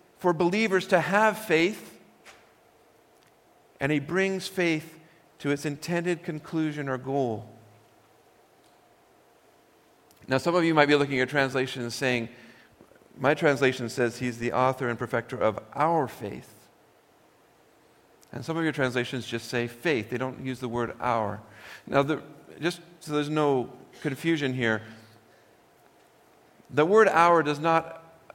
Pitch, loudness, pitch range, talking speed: 145 Hz, -26 LUFS, 125-165 Hz, 135 wpm